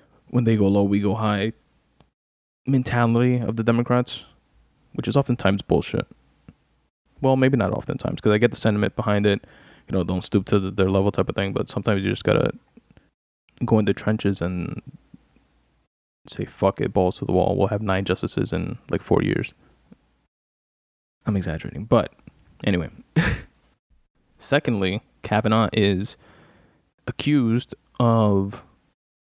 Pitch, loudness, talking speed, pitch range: 105 Hz, -22 LUFS, 145 wpm, 95-120 Hz